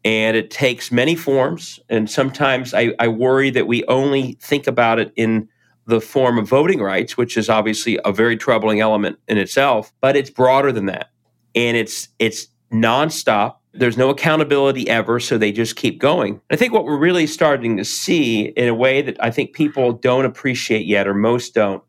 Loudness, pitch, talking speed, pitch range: -17 LUFS, 120 Hz, 190 wpm, 115-135 Hz